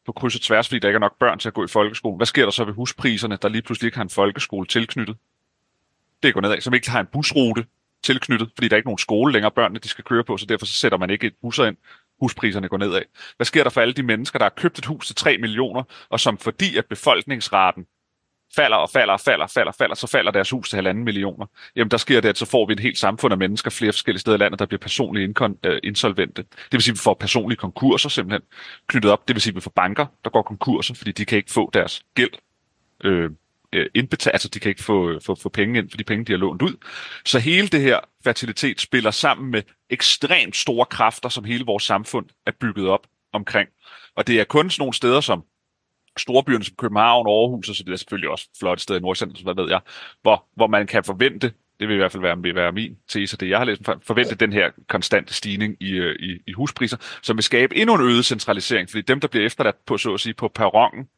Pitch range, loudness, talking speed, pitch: 100-125 Hz, -20 LUFS, 255 wpm, 110 Hz